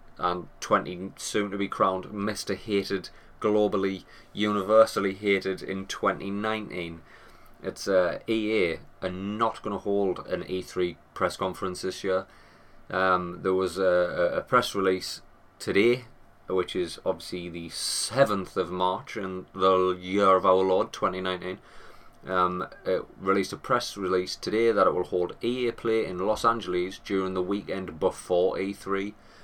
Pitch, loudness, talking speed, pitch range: 95 Hz, -27 LUFS, 145 wpm, 95-105 Hz